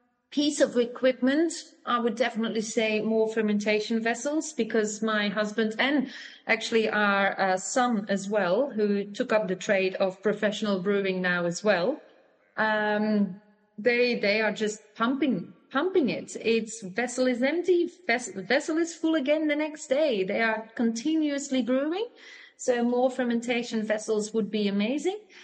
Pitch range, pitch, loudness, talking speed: 210-270 Hz, 230 Hz, -27 LUFS, 145 wpm